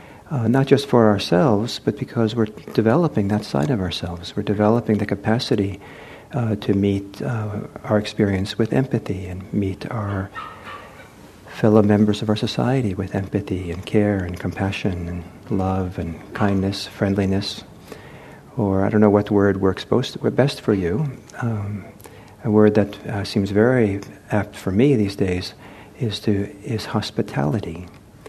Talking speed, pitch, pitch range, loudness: 150 wpm, 105 Hz, 100-110 Hz, -21 LUFS